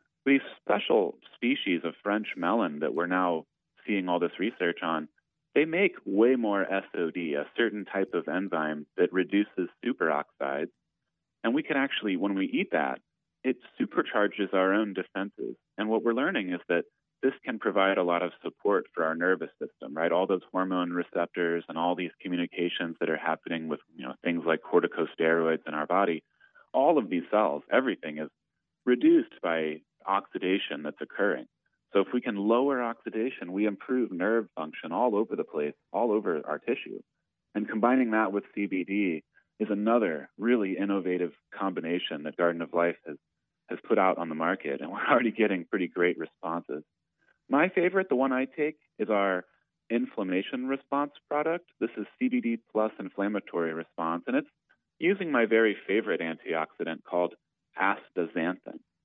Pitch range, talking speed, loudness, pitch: 85-115 Hz, 165 wpm, -29 LUFS, 95 Hz